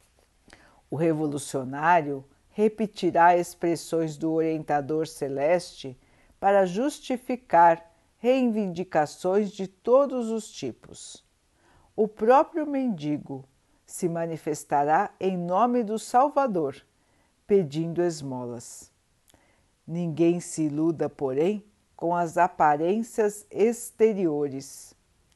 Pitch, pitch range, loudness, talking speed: 170 Hz, 145-210 Hz, -25 LUFS, 80 wpm